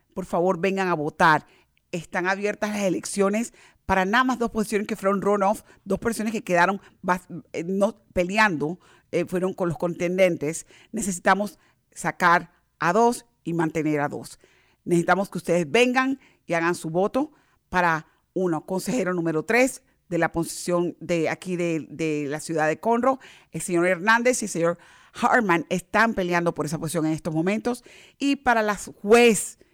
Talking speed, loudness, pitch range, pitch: 165 wpm, -24 LUFS, 170-215 Hz, 185 Hz